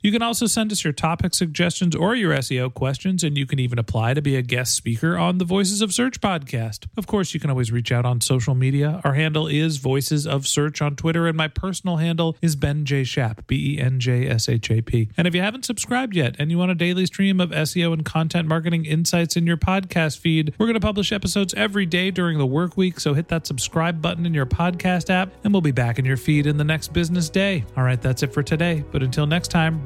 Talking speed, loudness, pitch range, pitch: 235 wpm, -21 LUFS, 140-180 Hz, 160 Hz